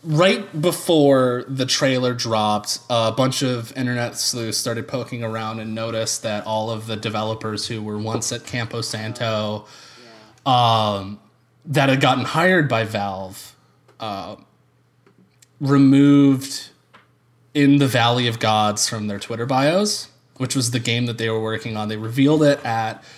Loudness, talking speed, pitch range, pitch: -20 LUFS, 150 wpm, 110-135 Hz, 120 Hz